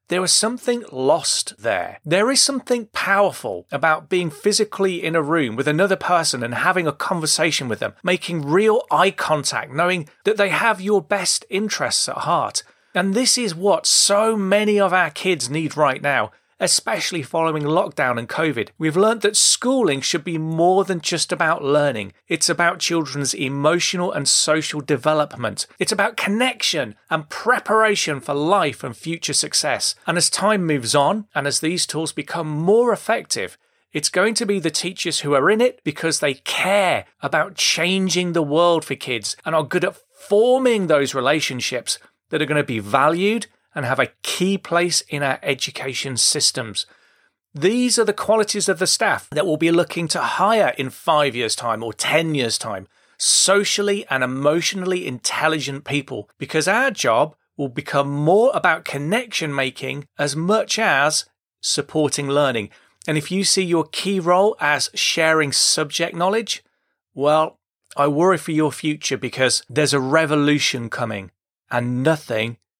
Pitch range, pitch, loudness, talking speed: 145-195 Hz, 160 Hz, -19 LUFS, 165 wpm